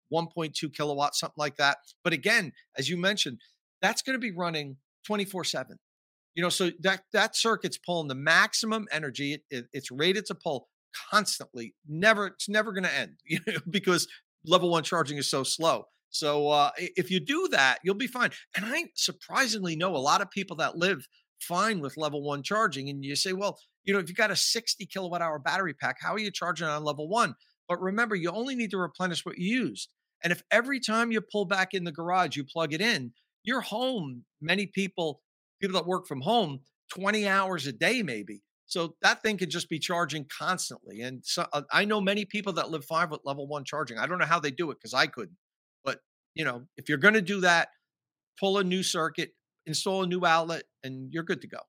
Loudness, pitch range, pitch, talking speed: -28 LUFS, 150-200 Hz, 175 Hz, 215 wpm